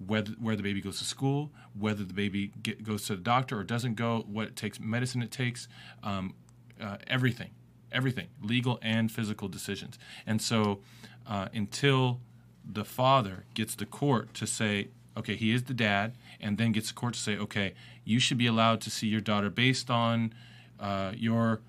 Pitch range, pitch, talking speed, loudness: 105-120 Hz, 110 Hz, 190 wpm, -31 LUFS